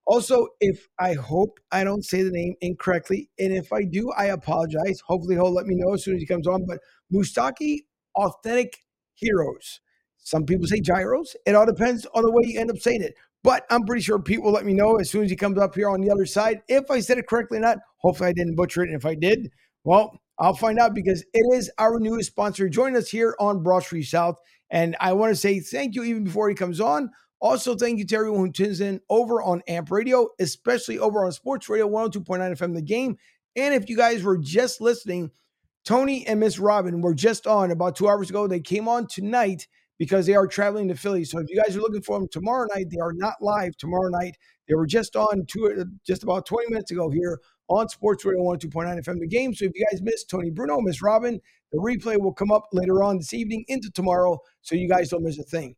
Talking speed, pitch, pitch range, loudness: 235 wpm, 200 Hz, 180-225 Hz, -23 LUFS